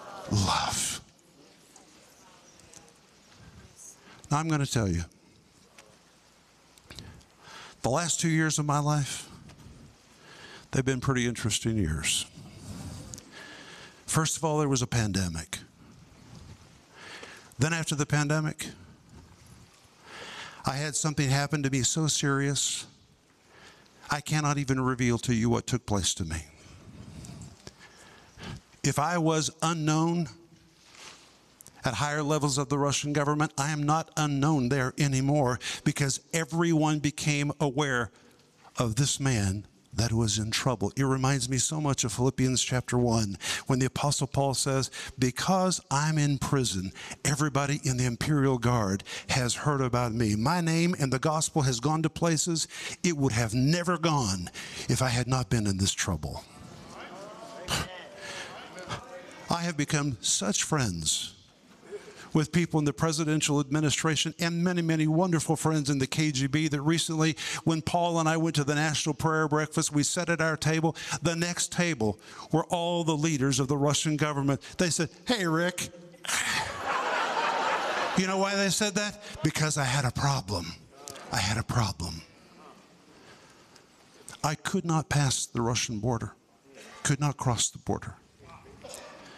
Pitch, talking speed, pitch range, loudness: 145 Hz, 135 wpm, 125-160 Hz, -28 LUFS